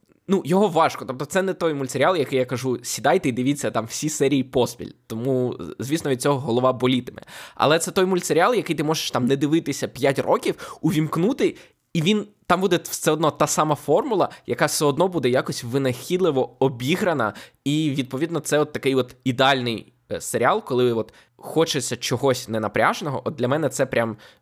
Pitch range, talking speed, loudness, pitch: 125-160 Hz, 175 wpm, -22 LUFS, 140 Hz